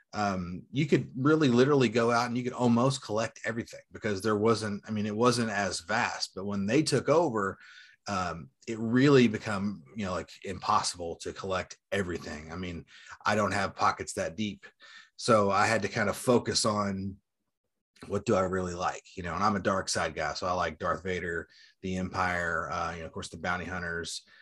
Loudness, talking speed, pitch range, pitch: -29 LUFS, 200 wpm, 90-120 Hz, 100 Hz